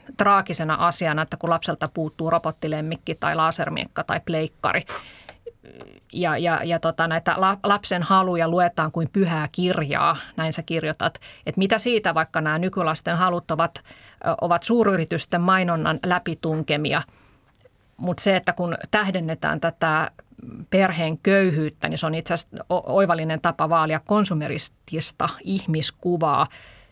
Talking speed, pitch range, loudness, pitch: 125 wpm, 160-180 Hz, -23 LUFS, 165 Hz